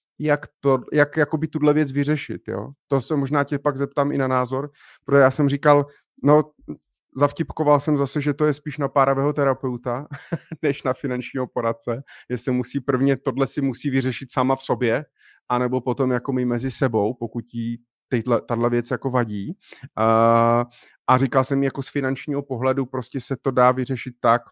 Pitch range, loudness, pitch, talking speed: 125-145 Hz, -22 LUFS, 135 Hz, 175 wpm